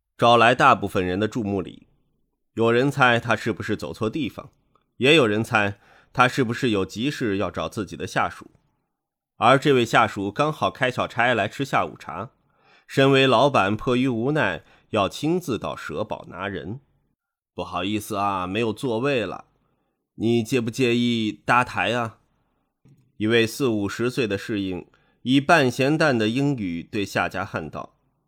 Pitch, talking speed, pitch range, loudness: 110 Hz, 230 characters per minute, 100-125 Hz, -22 LUFS